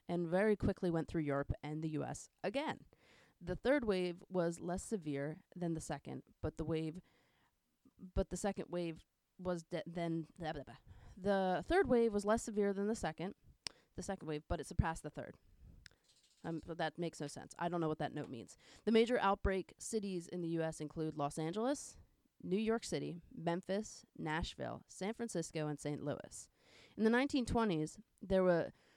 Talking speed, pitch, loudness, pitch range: 180 wpm, 170 Hz, -39 LUFS, 155-195 Hz